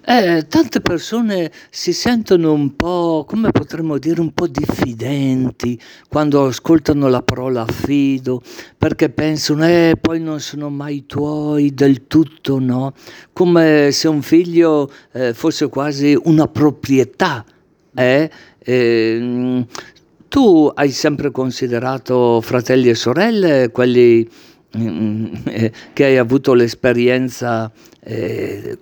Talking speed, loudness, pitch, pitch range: 110 wpm, -15 LUFS, 140 Hz, 125-160 Hz